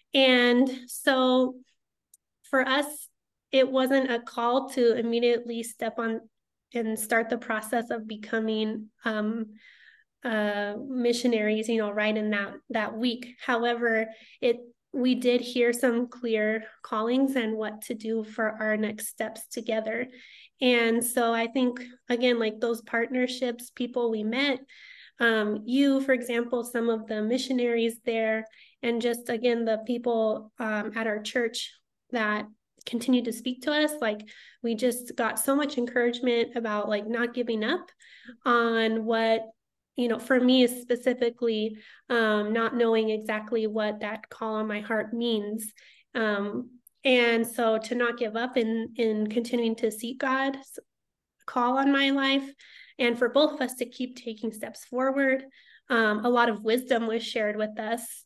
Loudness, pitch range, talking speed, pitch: -27 LUFS, 220-250 Hz, 150 wpm, 235 Hz